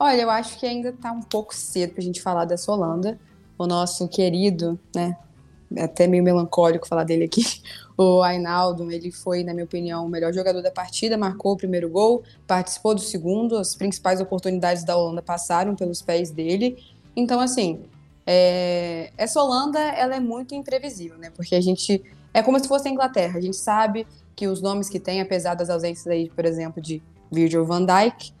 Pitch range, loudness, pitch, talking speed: 175-215 Hz, -23 LUFS, 180 Hz, 190 wpm